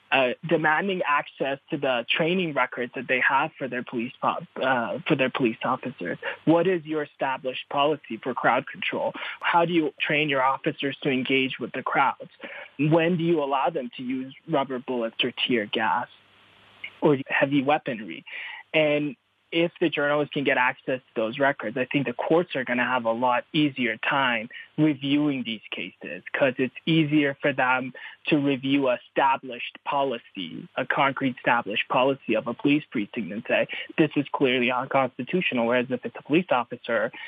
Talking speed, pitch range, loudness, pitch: 170 wpm, 130-155 Hz, -25 LUFS, 140 Hz